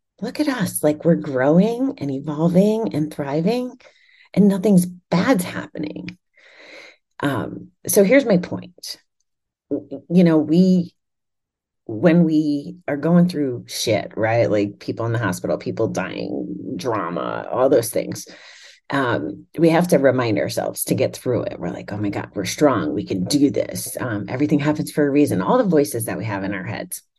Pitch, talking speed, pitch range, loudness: 160 Hz, 170 wpm, 145-195 Hz, -20 LUFS